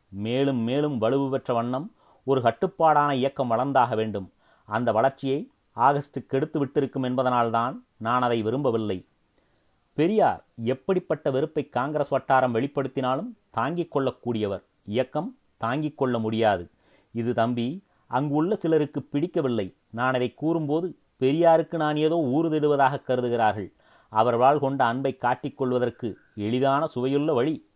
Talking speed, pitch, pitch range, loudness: 115 wpm, 135 Hz, 120-150 Hz, -25 LUFS